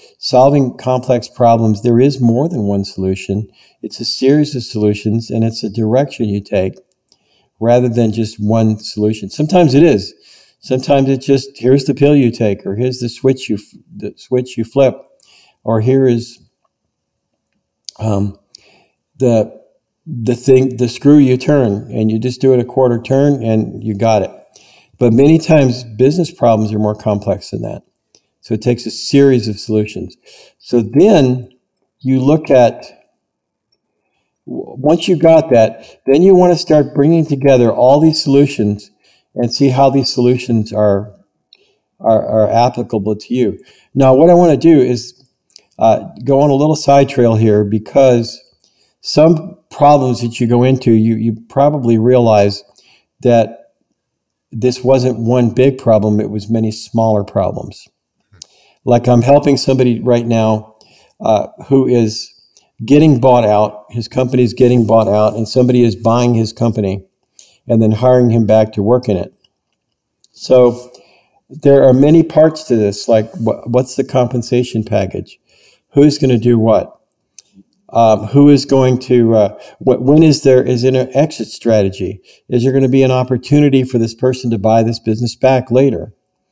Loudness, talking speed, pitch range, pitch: -12 LUFS, 160 wpm, 110-135 Hz, 125 Hz